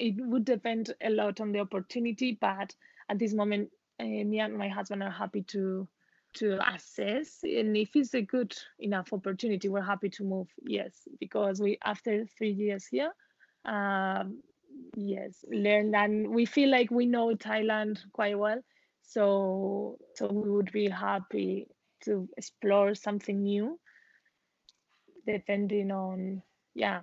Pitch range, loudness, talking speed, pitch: 200-230 Hz, -31 LUFS, 145 wpm, 210 Hz